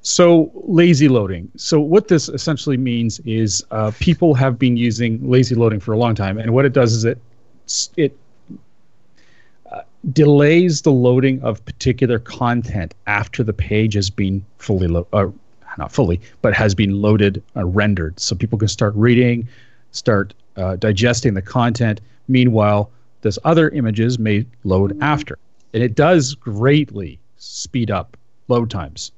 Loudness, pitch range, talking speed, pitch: -17 LUFS, 105-130 Hz, 155 wpm, 115 Hz